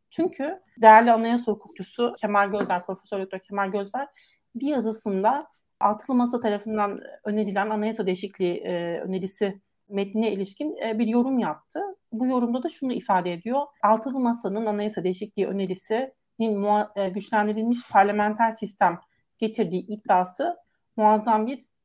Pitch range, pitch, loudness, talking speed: 200-240 Hz, 215 Hz, -25 LUFS, 115 wpm